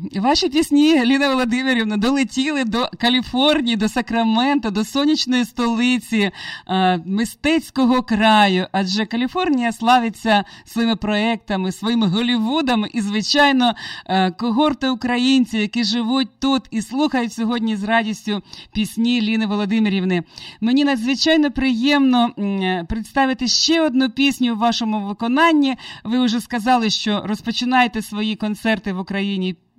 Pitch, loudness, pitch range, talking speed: 235 Hz, -18 LUFS, 215-260 Hz, 115 wpm